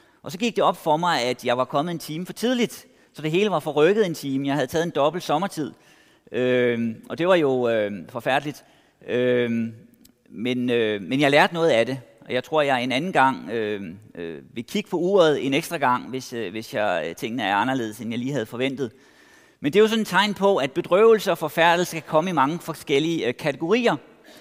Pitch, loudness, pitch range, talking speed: 140 Hz, -22 LUFS, 125-170 Hz, 225 wpm